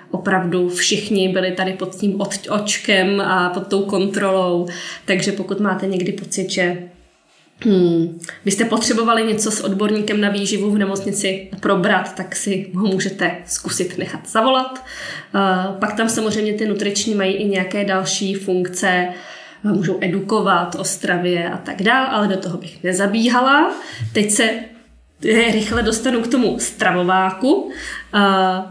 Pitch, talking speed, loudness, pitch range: 195 Hz, 140 wpm, -18 LUFS, 185-215 Hz